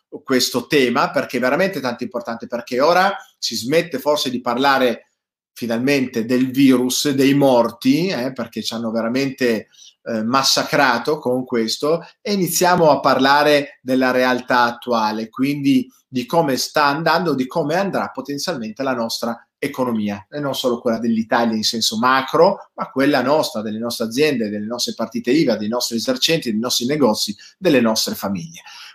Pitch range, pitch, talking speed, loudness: 115-145 Hz, 130 Hz, 155 wpm, -18 LUFS